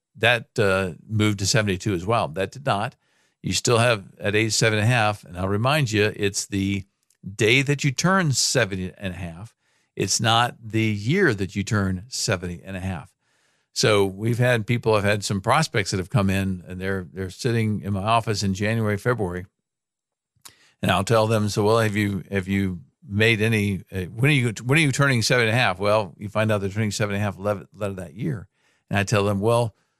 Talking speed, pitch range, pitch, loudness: 215 wpm, 100-115 Hz, 105 Hz, -22 LUFS